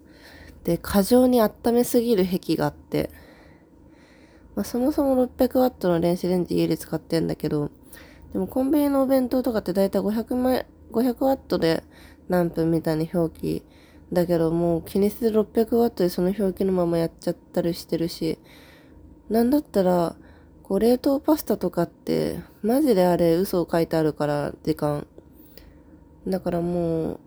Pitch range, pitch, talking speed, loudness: 165-235 Hz, 180 Hz, 310 characters per minute, -23 LUFS